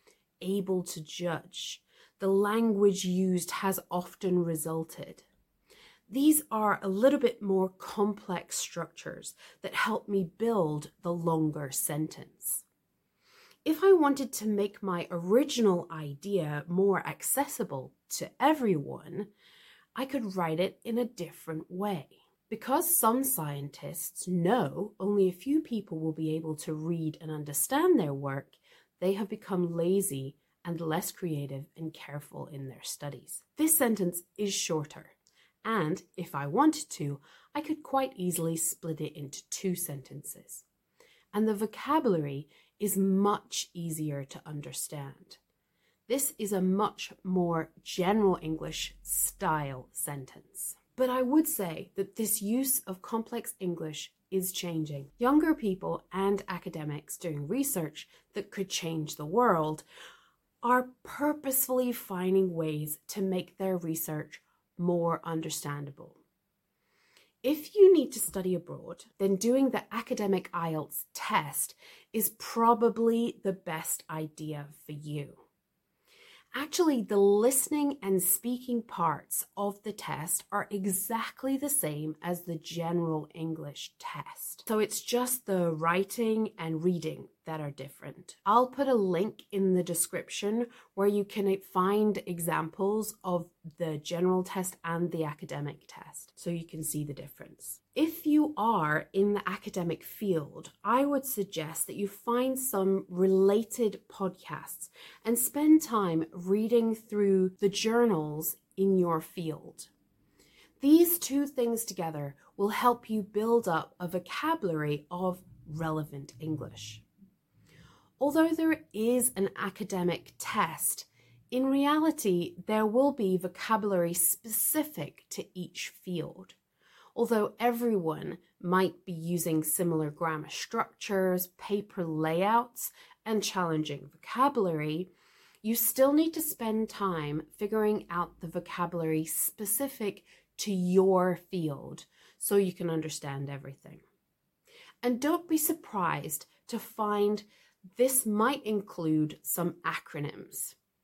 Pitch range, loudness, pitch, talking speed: 165-225 Hz, -30 LUFS, 190 Hz, 125 wpm